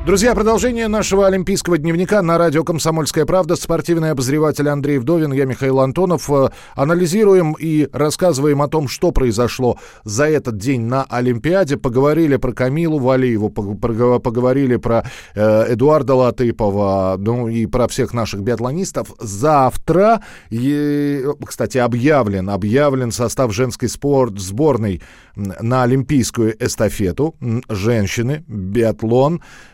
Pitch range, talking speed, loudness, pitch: 115-155 Hz, 110 wpm, -16 LUFS, 130 Hz